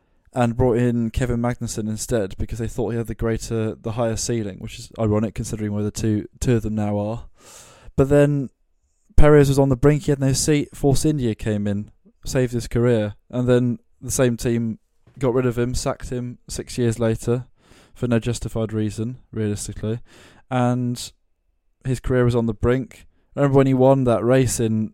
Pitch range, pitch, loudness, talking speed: 110-125 Hz, 120 Hz, -21 LUFS, 190 wpm